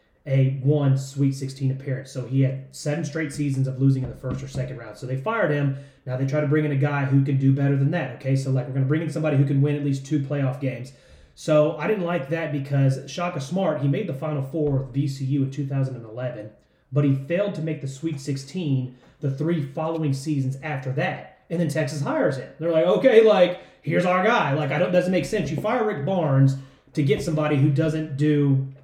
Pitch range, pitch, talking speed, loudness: 135-155 Hz, 140 Hz, 235 wpm, -23 LUFS